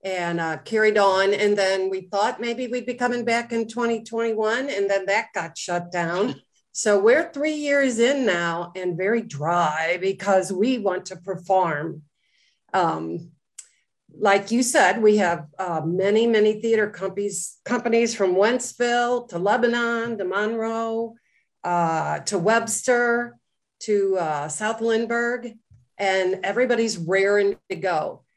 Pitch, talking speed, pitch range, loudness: 205 Hz, 135 wpm, 185-230 Hz, -22 LUFS